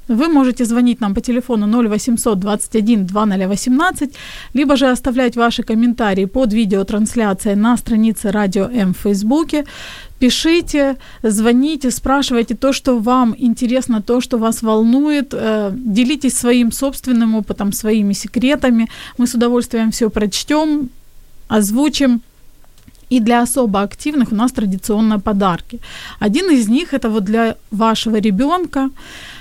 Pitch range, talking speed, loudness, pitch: 220-260 Hz, 120 wpm, -15 LUFS, 235 Hz